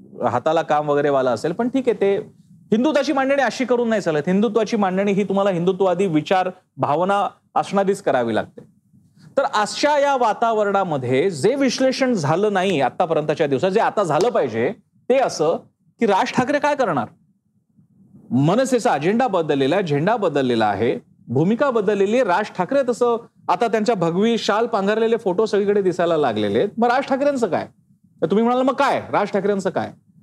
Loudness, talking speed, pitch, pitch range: -19 LUFS, 160 wpm, 205 Hz, 180-240 Hz